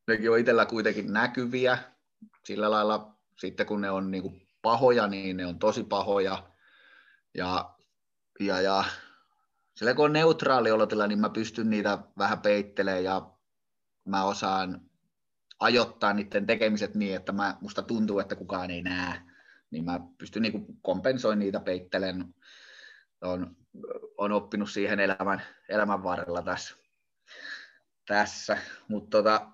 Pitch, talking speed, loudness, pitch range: 105 Hz, 135 wpm, -28 LUFS, 95-115 Hz